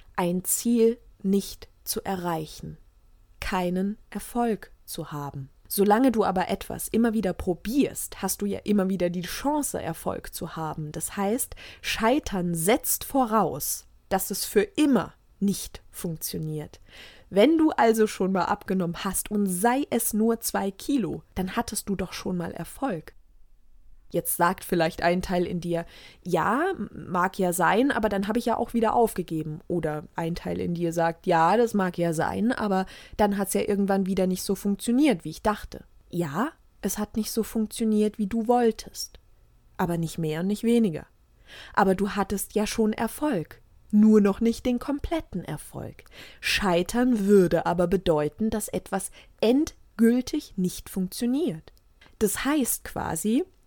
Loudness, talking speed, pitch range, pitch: -26 LUFS, 155 wpm, 175-230 Hz, 200 Hz